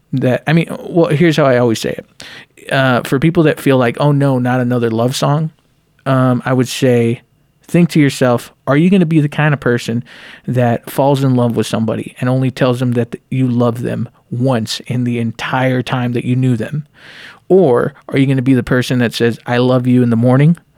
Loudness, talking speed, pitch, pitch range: -14 LUFS, 225 wpm, 130 Hz, 120-145 Hz